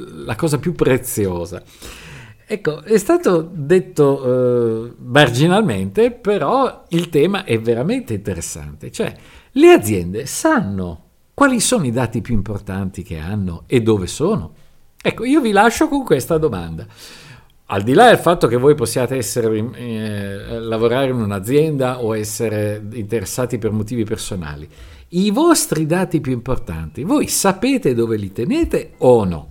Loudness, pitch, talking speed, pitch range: -17 LUFS, 125 Hz, 140 wpm, 105-170 Hz